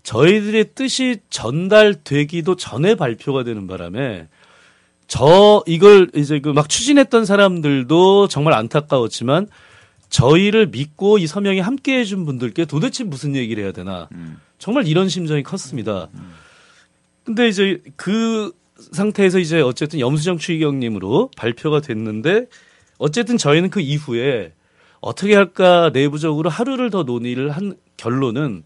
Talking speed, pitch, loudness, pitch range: 300 characters per minute, 160 Hz, -16 LUFS, 130-200 Hz